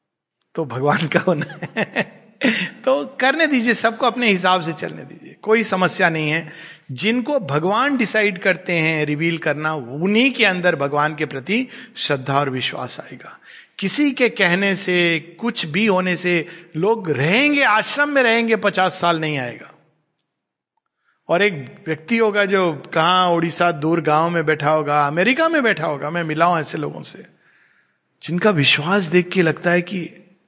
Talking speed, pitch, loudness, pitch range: 160 wpm, 175 Hz, -18 LUFS, 155-215 Hz